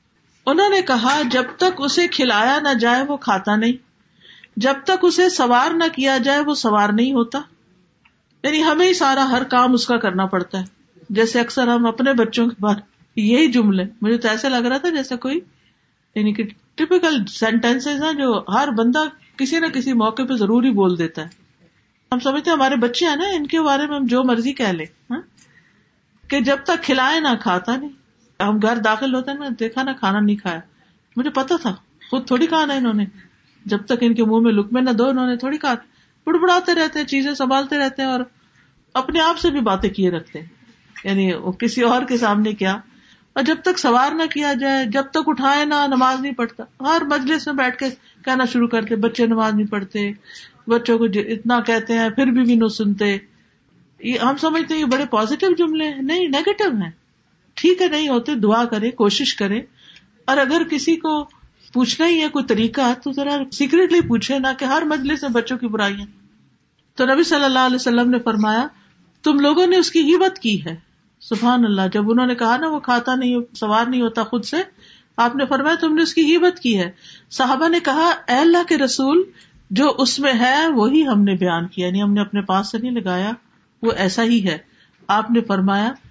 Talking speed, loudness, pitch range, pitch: 205 wpm, -18 LUFS, 225-290 Hz, 255 Hz